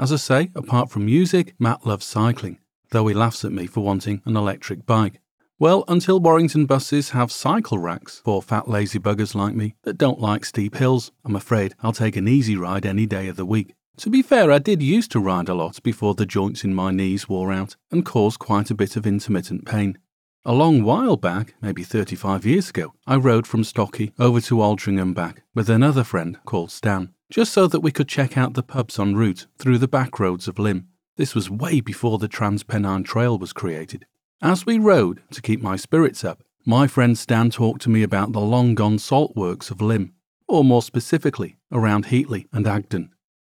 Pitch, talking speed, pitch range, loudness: 110 Hz, 210 wpm, 100-130 Hz, -20 LUFS